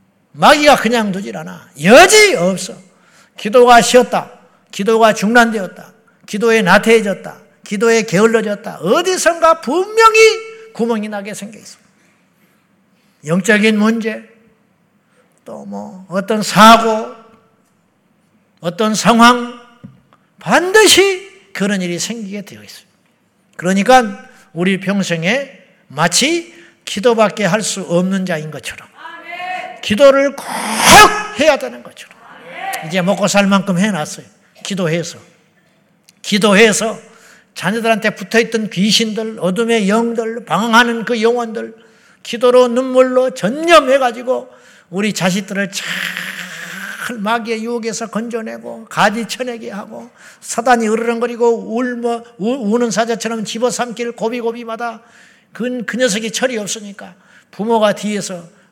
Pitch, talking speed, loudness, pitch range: 225 Hz, 250 characters per minute, -13 LUFS, 200-240 Hz